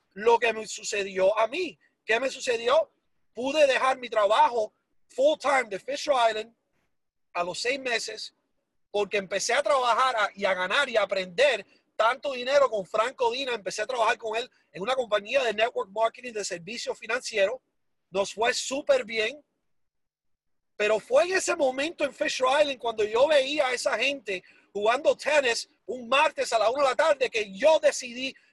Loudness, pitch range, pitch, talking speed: -26 LUFS, 215-285 Hz, 250 Hz, 170 wpm